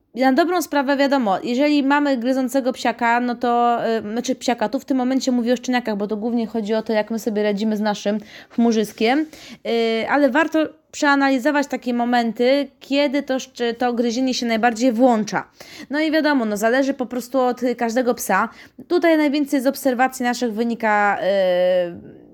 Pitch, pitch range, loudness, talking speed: 250 Hz, 230-275 Hz, -20 LUFS, 170 wpm